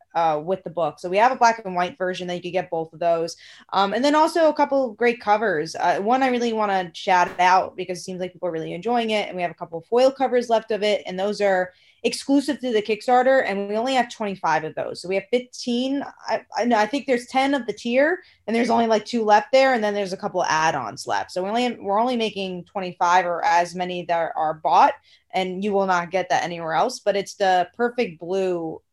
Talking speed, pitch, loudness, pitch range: 255 wpm, 200 Hz, -22 LUFS, 180-240 Hz